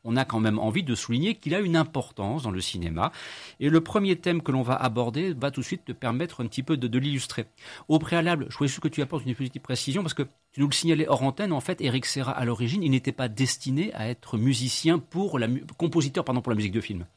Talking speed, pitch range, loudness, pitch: 265 wpm, 120-160 Hz, -27 LUFS, 135 Hz